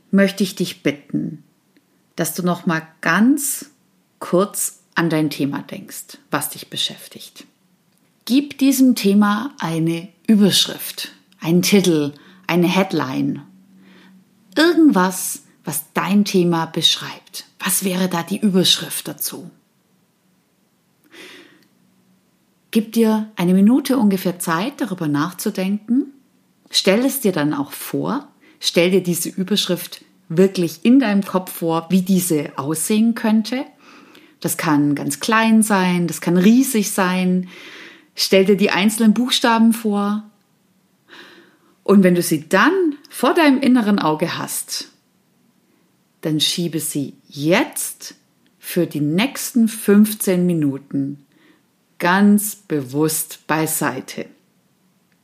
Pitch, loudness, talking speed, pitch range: 190 Hz, -18 LUFS, 110 wpm, 170-215 Hz